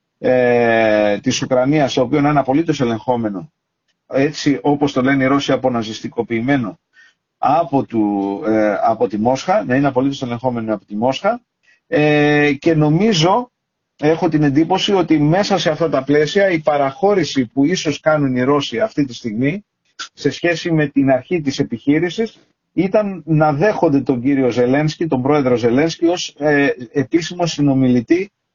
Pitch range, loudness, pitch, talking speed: 125-160 Hz, -16 LUFS, 145 Hz, 145 wpm